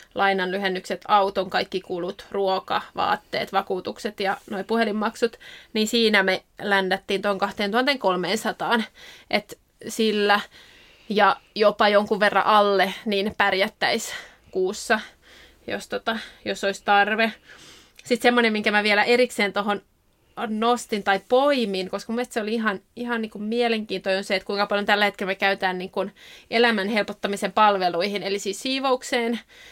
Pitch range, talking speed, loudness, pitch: 195-225 Hz, 135 wpm, -23 LUFS, 205 Hz